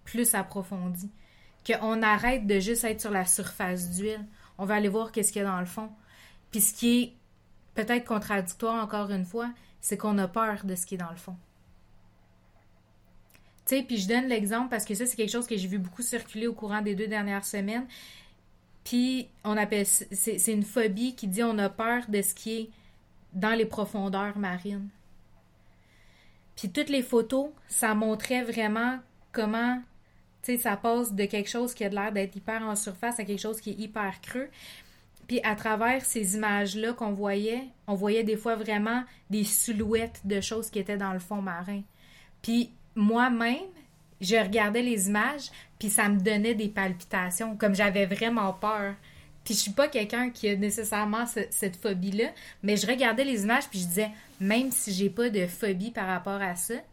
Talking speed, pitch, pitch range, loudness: 190 wpm, 215 Hz, 200-230 Hz, -28 LUFS